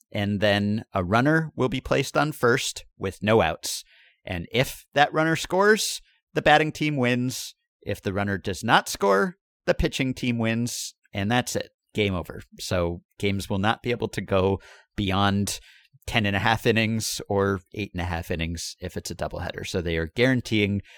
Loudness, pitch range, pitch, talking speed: -25 LUFS, 100-130 Hz, 110 Hz, 185 wpm